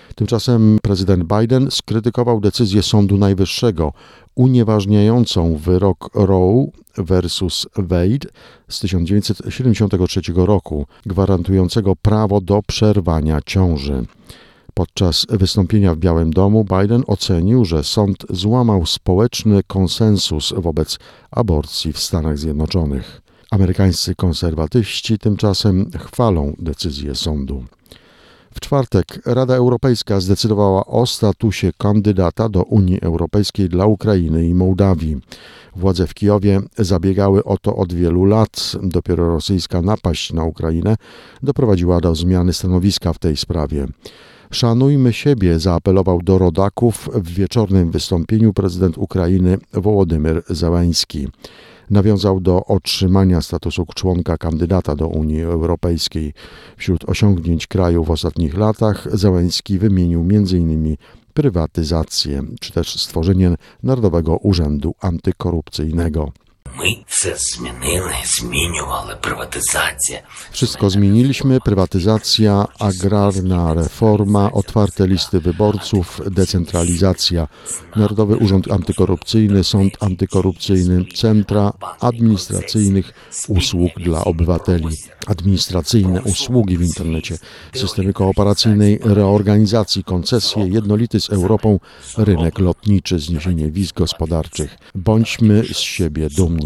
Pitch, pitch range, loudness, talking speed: 95 Hz, 85-105 Hz, -16 LUFS, 95 wpm